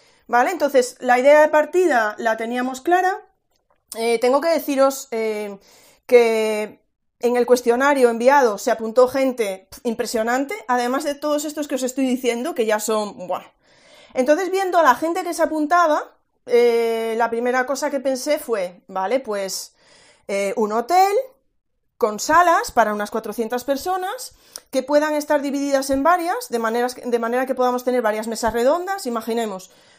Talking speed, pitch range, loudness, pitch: 155 wpm, 230-300 Hz, -20 LUFS, 250 Hz